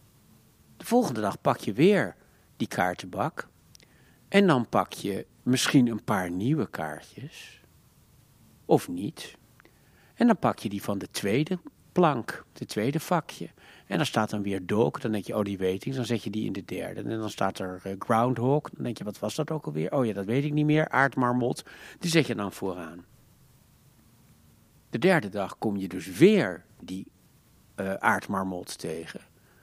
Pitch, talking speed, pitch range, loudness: 110 Hz, 180 wpm, 95-135 Hz, -27 LUFS